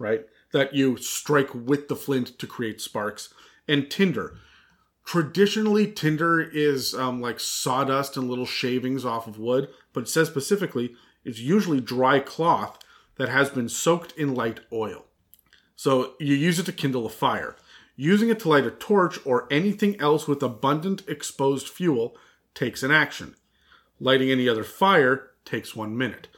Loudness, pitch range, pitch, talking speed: -24 LUFS, 125-160 Hz, 140 Hz, 160 wpm